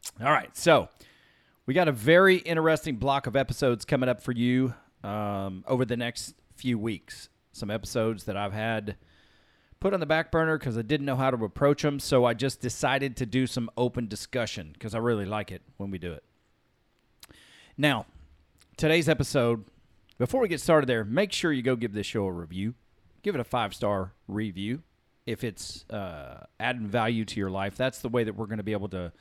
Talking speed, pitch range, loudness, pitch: 200 wpm, 105-135 Hz, -28 LUFS, 120 Hz